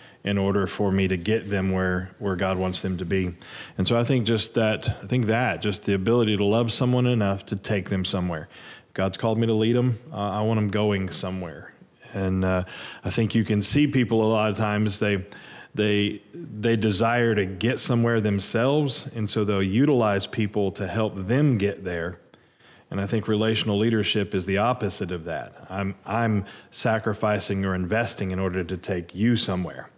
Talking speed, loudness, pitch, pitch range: 195 wpm, -24 LUFS, 105 Hz, 95-115 Hz